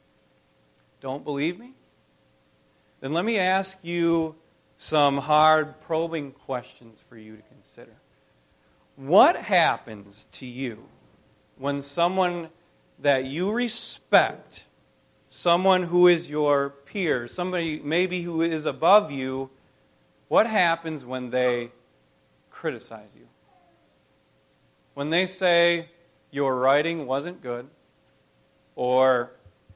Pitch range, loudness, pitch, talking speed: 105-170 Hz, -24 LUFS, 140 Hz, 100 wpm